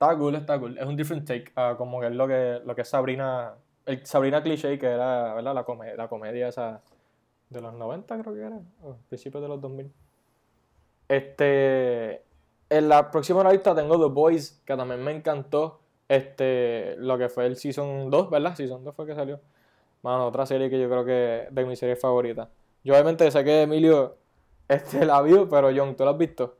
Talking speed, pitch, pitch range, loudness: 210 wpm, 135 Hz, 125-150 Hz, -24 LUFS